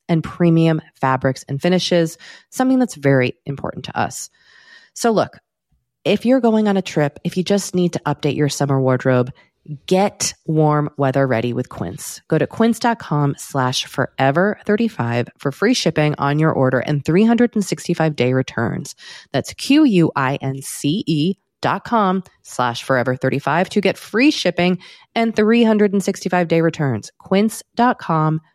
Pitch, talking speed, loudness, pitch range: 160 Hz, 140 wpm, -18 LUFS, 140-195 Hz